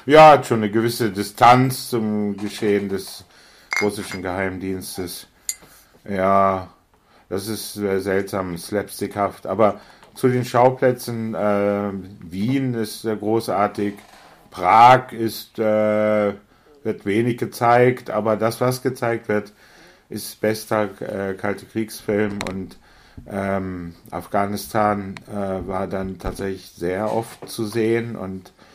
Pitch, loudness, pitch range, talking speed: 105 Hz, -20 LUFS, 95-115 Hz, 115 wpm